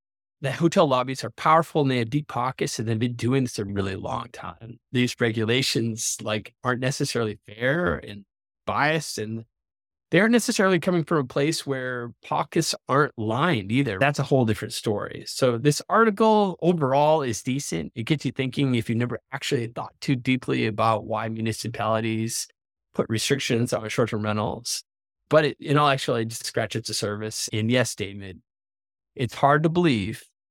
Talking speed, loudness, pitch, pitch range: 170 wpm, -24 LUFS, 125 Hz, 110-145 Hz